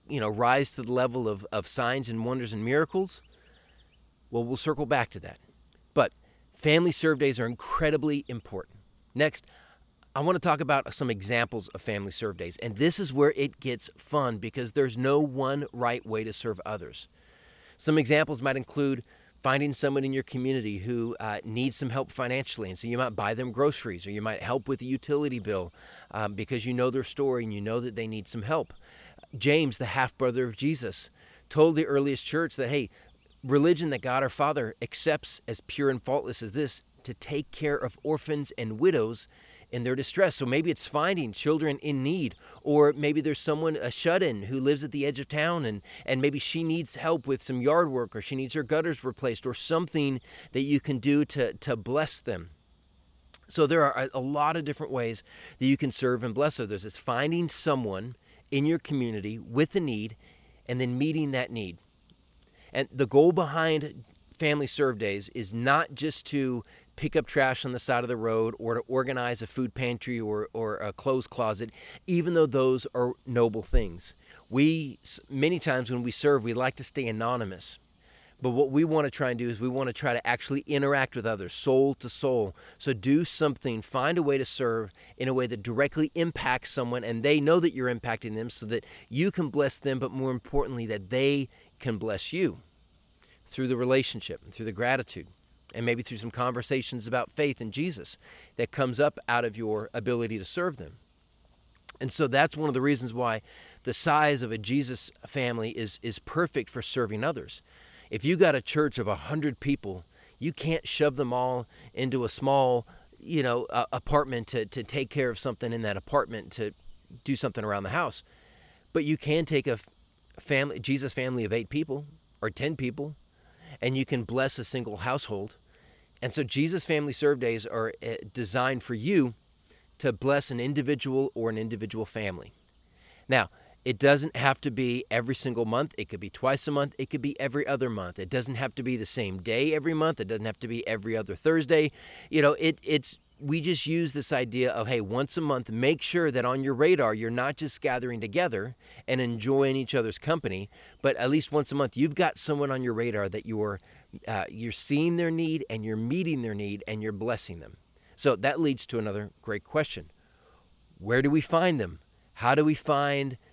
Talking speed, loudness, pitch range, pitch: 200 wpm, -29 LUFS, 115-145 Hz, 130 Hz